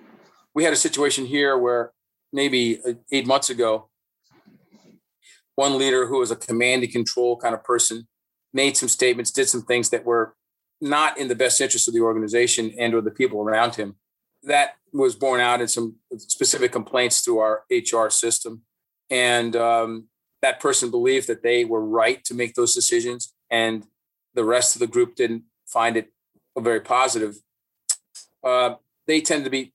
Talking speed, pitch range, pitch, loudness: 170 wpm, 115-135 Hz, 120 Hz, -21 LUFS